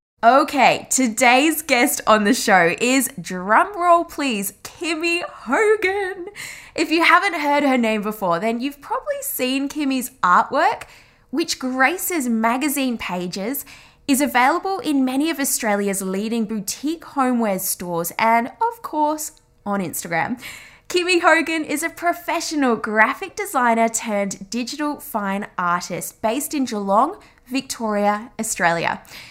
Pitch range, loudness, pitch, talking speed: 215-315 Hz, -19 LUFS, 260 Hz, 120 wpm